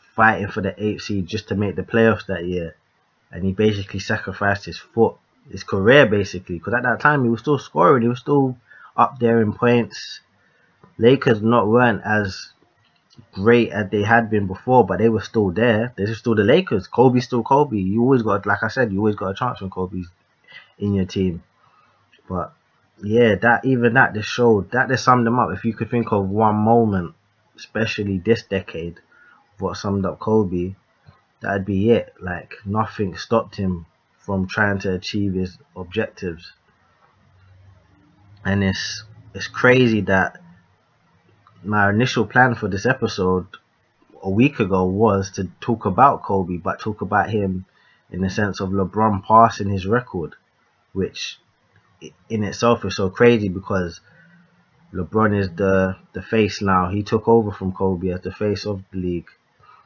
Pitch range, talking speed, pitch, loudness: 95-115 Hz, 170 wpm, 105 Hz, -19 LUFS